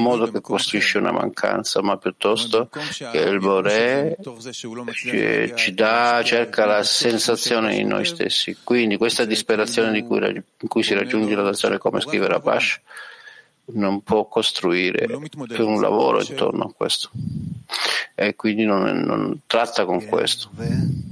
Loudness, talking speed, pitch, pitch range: -20 LUFS, 140 wpm, 115 Hz, 105-120 Hz